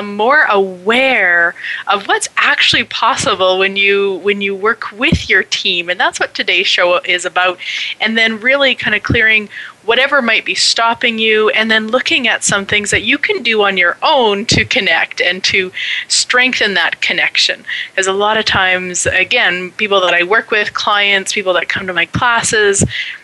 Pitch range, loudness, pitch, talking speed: 185-230 Hz, -12 LUFS, 205 Hz, 180 wpm